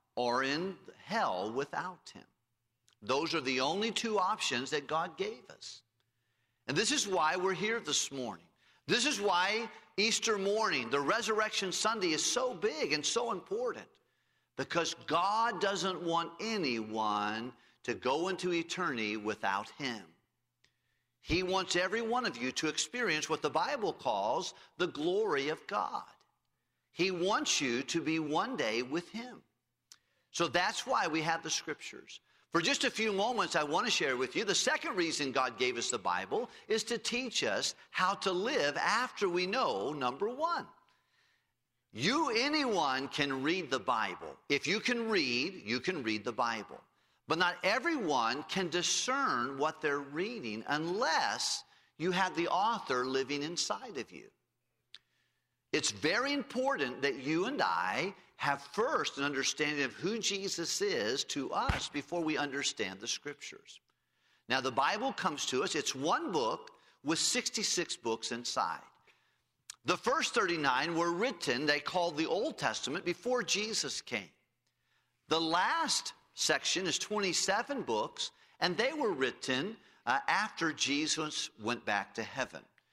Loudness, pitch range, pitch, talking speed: -33 LUFS, 140-225 Hz, 170 Hz, 150 wpm